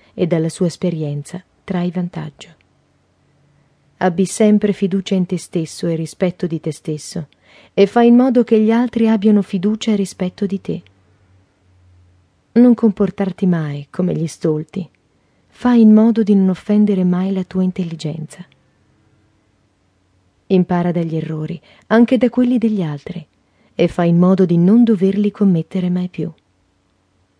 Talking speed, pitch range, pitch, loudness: 140 wpm, 145-200 Hz, 180 Hz, -16 LUFS